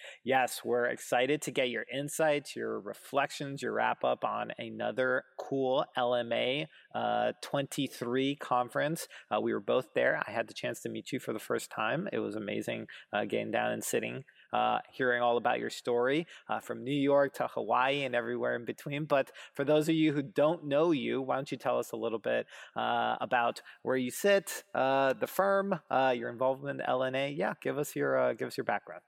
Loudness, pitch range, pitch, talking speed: -32 LUFS, 125-145 Hz, 135 Hz, 200 wpm